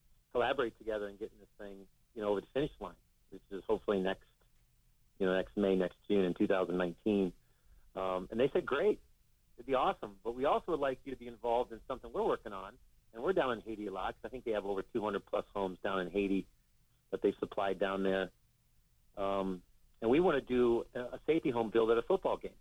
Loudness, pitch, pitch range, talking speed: -35 LUFS, 100 Hz, 95-115 Hz, 225 wpm